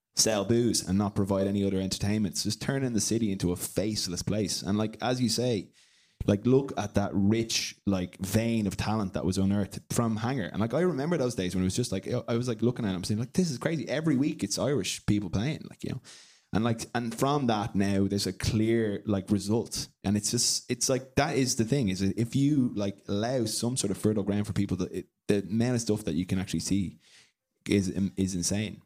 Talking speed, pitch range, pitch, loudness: 230 wpm, 100-120 Hz, 105 Hz, -29 LUFS